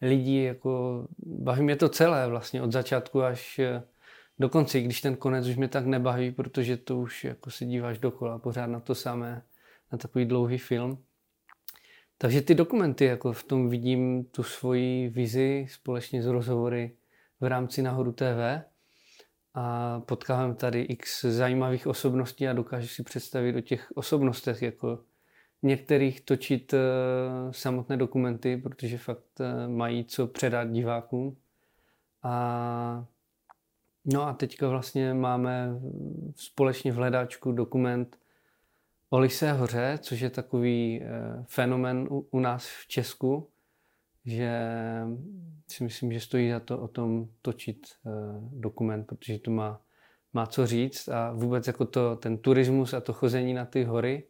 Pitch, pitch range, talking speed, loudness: 125 Hz, 120-130 Hz, 135 wpm, -29 LUFS